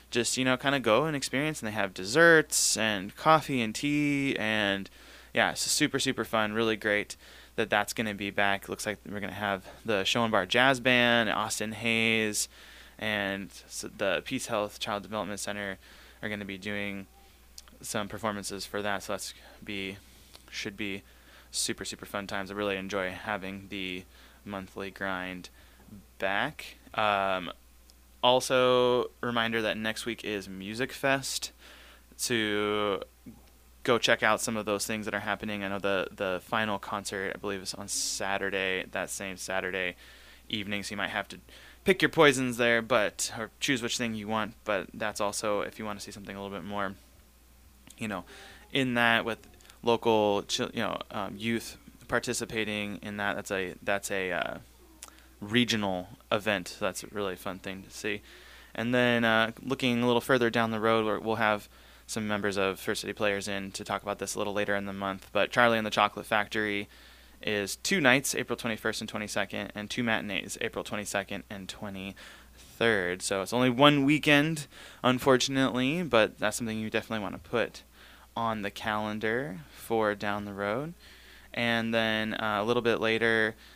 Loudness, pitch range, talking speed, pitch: -29 LUFS, 100-115 Hz, 175 wpm, 105 Hz